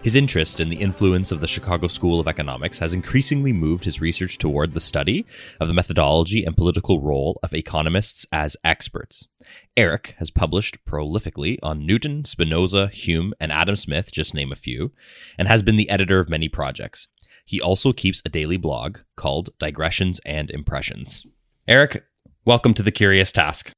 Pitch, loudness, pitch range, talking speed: 90 Hz, -21 LUFS, 80-100 Hz, 170 wpm